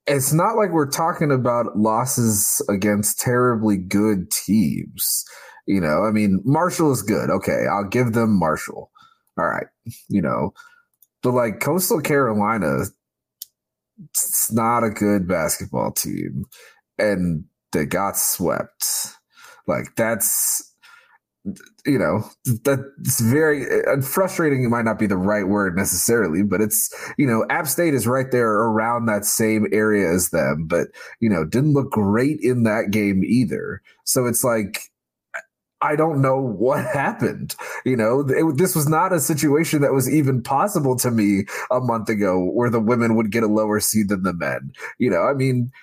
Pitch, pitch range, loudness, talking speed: 120 Hz, 105-140 Hz, -20 LUFS, 160 wpm